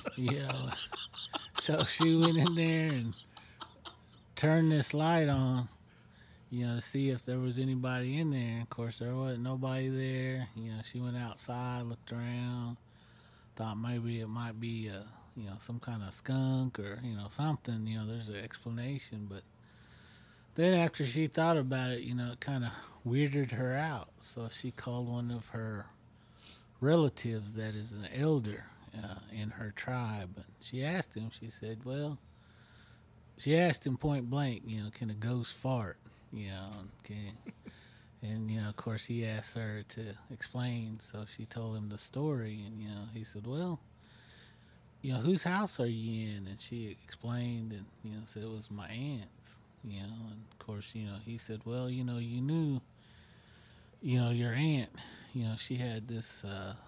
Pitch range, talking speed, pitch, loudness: 110-130 Hz, 180 wpm, 115 Hz, -36 LUFS